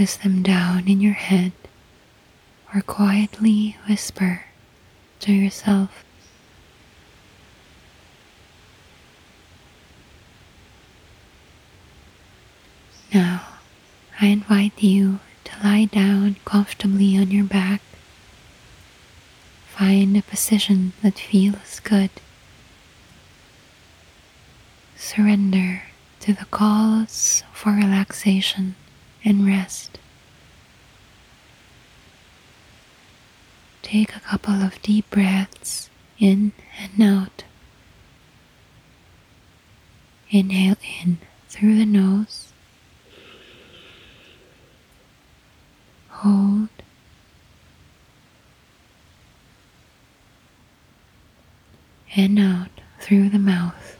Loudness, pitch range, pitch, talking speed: -19 LUFS, 190-205 Hz, 200 Hz, 60 wpm